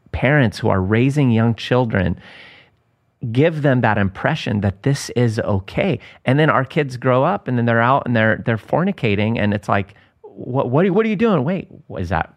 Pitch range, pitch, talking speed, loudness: 105-140 Hz, 120 Hz, 205 wpm, -18 LUFS